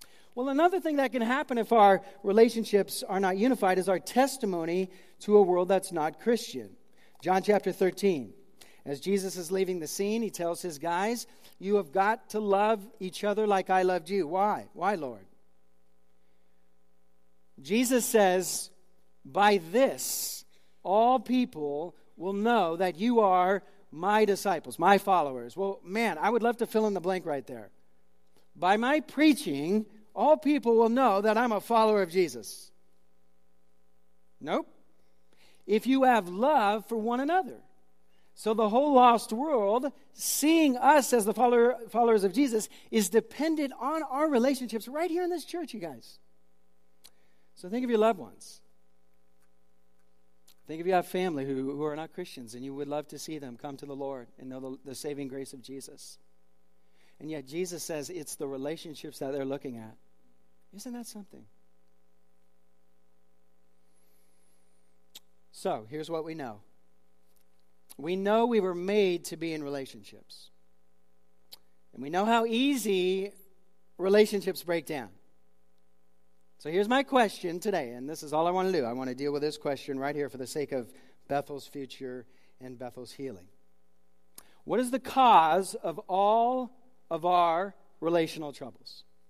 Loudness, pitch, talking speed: -28 LUFS, 170 Hz, 155 wpm